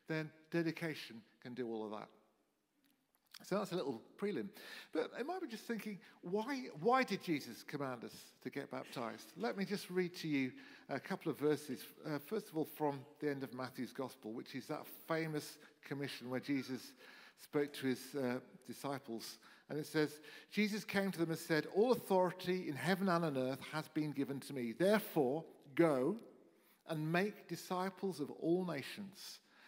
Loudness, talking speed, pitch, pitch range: -41 LUFS, 180 wpm, 155 Hz, 140-195 Hz